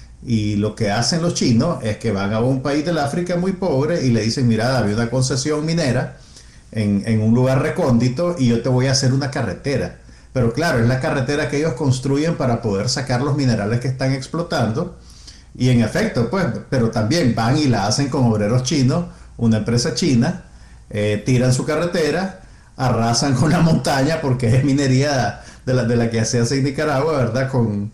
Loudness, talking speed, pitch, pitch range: -18 LUFS, 195 wpm, 130 Hz, 115-145 Hz